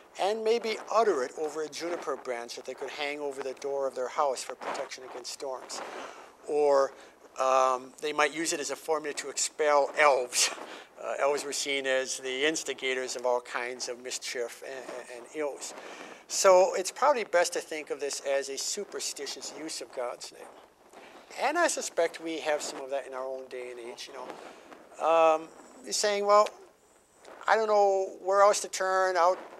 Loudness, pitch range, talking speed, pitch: -29 LUFS, 130-190 Hz, 190 wpm, 150 Hz